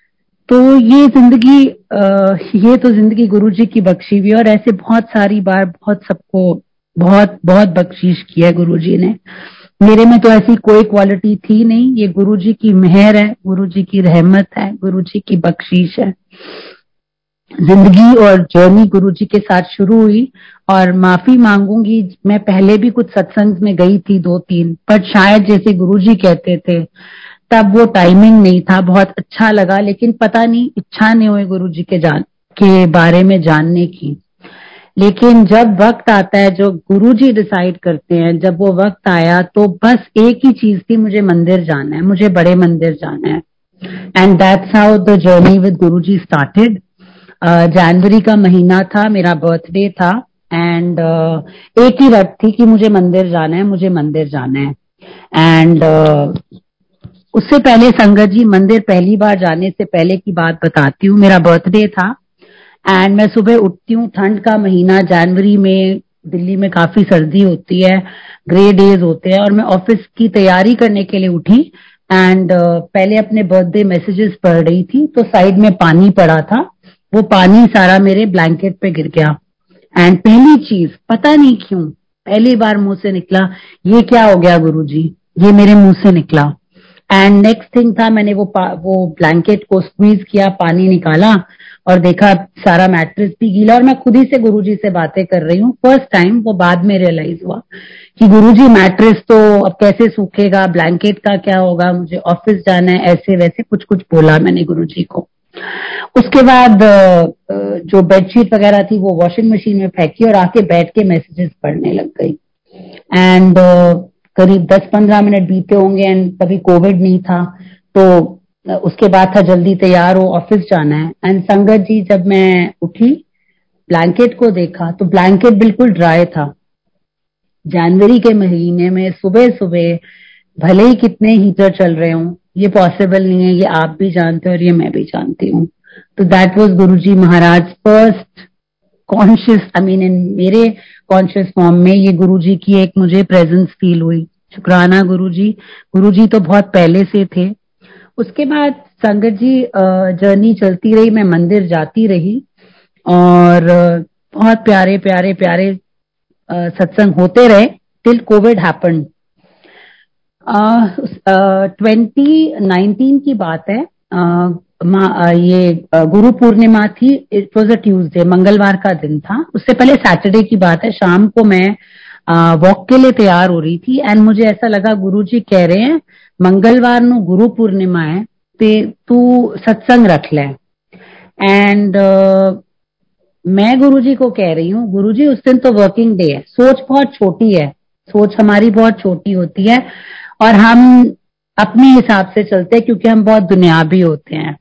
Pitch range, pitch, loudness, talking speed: 180-215 Hz, 195 Hz, -9 LUFS, 165 wpm